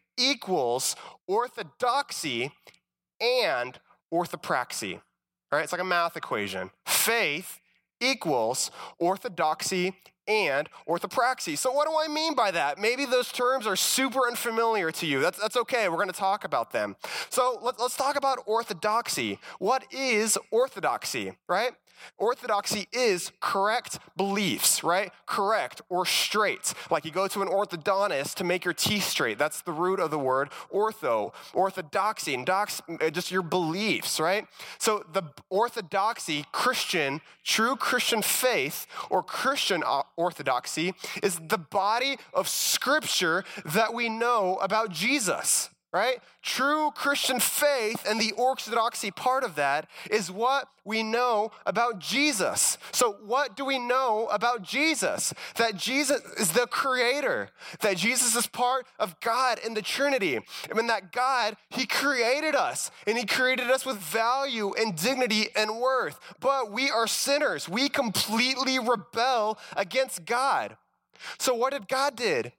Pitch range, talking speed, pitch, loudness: 195-260 Hz, 140 wpm, 225 Hz, -27 LUFS